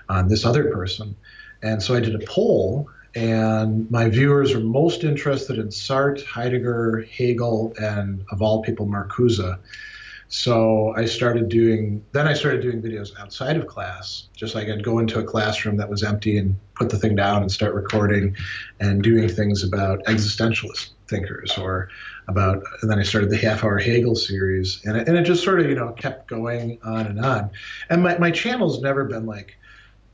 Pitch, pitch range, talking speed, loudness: 110 Hz, 105-120 Hz, 185 wpm, -21 LUFS